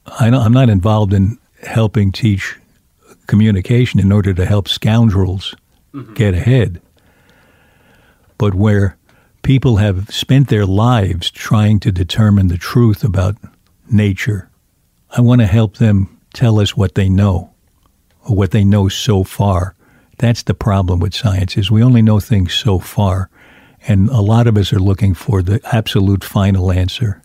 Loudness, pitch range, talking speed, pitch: -14 LUFS, 95-115 Hz, 155 wpm, 105 Hz